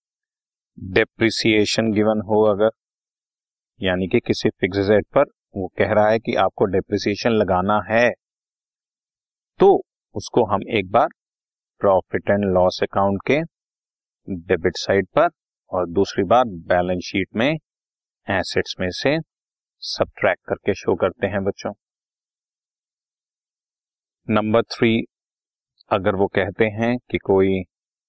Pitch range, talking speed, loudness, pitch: 95-110 Hz, 115 wpm, -20 LUFS, 105 Hz